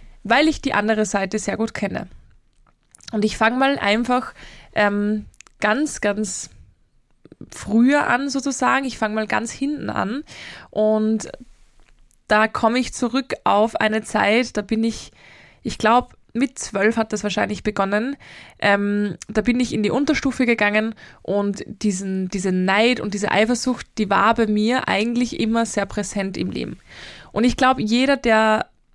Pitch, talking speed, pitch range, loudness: 220 Hz, 155 wpm, 210-250 Hz, -20 LUFS